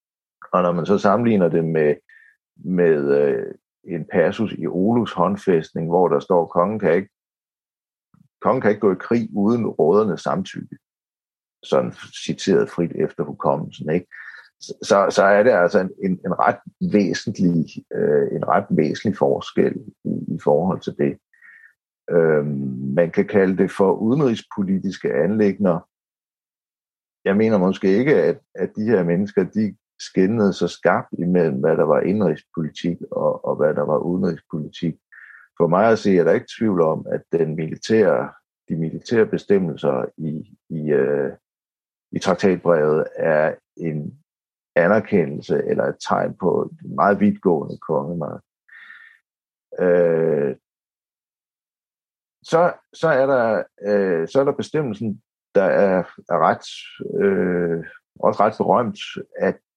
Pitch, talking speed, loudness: 100 Hz, 130 wpm, -20 LUFS